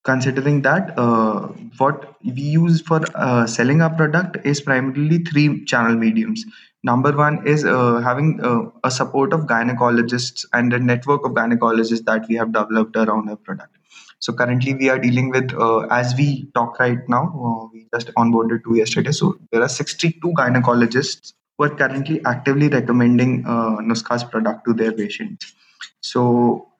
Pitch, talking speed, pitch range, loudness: 125 Hz, 165 wpm, 115-145 Hz, -18 LUFS